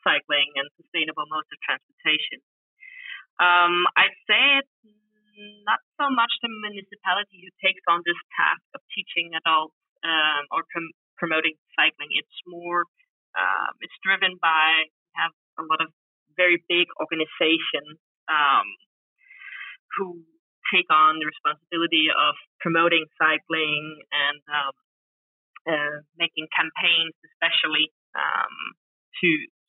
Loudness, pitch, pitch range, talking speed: -22 LUFS, 170 Hz, 155-210 Hz, 115 wpm